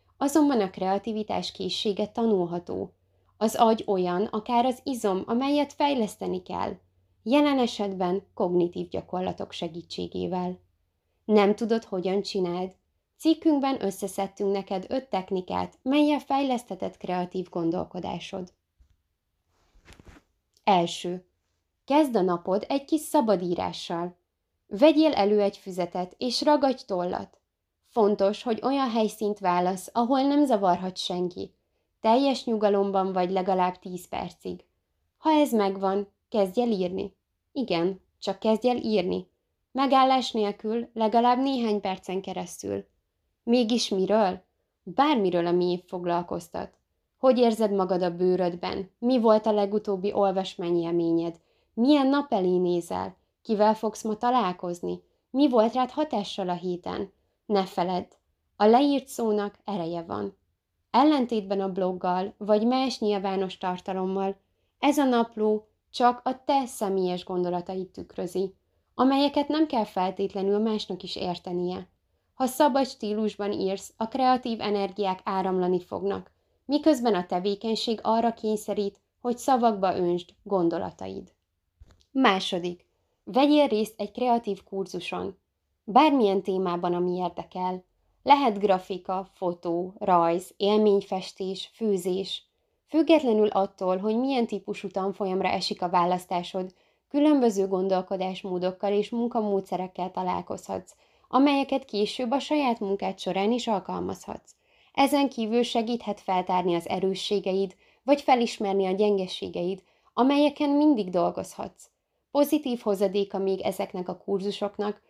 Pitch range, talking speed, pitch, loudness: 180-235 Hz, 110 wpm, 200 Hz, -26 LUFS